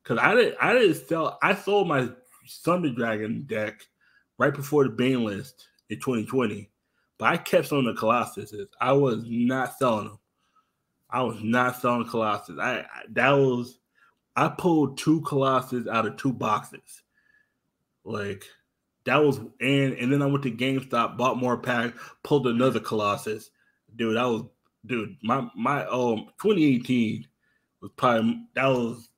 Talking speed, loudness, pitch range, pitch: 155 wpm, -25 LUFS, 115-140 Hz, 125 Hz